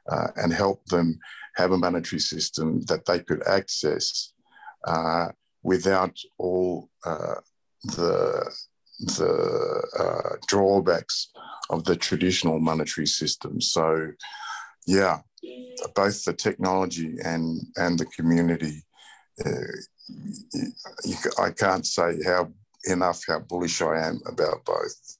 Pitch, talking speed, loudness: 95 Hz, 110 wpm, -26 LUFS